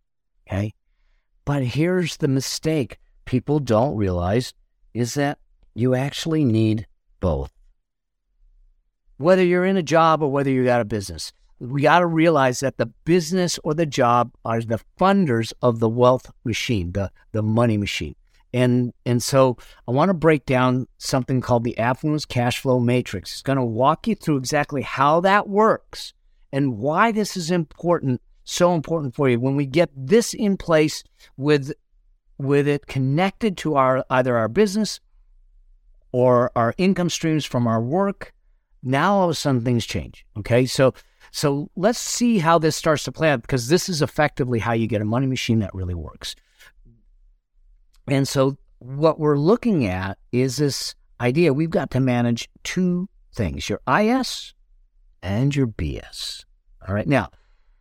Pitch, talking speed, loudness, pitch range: 135 Hz, 160 wpm, -21 LUFS, 120-160 Hz